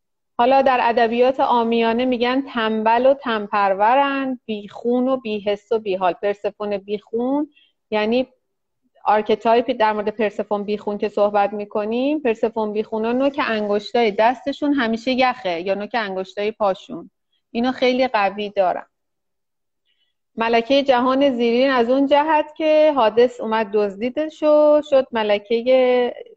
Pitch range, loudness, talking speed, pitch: 215-260 Hz, -19 LUFS, 120 wpm, 230 Hz